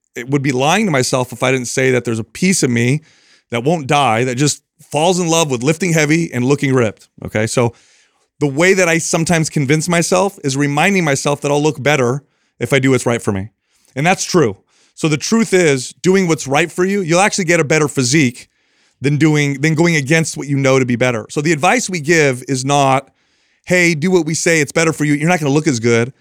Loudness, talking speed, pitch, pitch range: -15 LUFS, 240 wpm, 150 Hz, 130-170 Hz